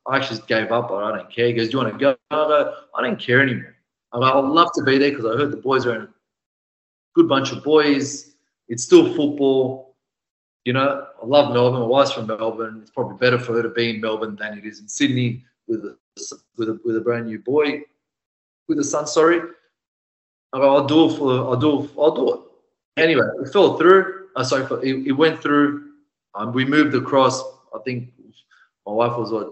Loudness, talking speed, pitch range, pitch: -19 LUFS, 205 wpm, 115-150 Hz, 130 Hz